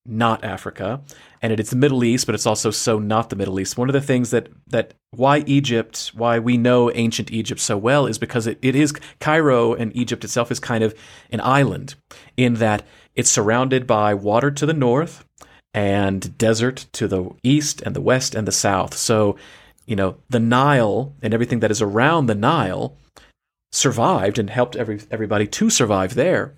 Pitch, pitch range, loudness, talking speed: 115 Hz, 110-130 Hz, -19 LUFS, 190 wpm